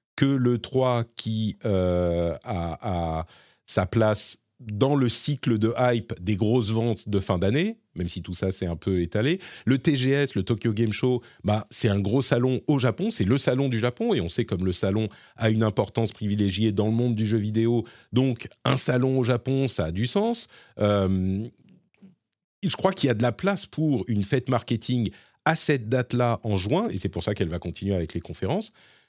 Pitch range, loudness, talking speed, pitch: 100-130 Hz, -25 LUFS, 205 wpm, 115 Hz